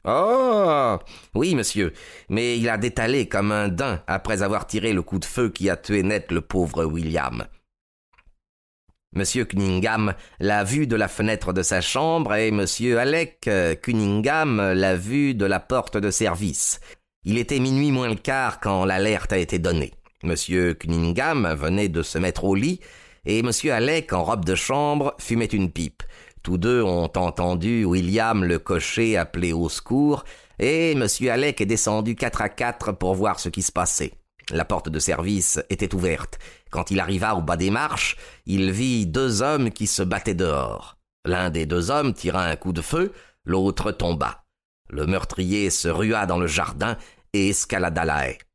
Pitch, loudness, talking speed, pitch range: 100 Hz, -23 LUFS, 175 wpm, 90-115 Hz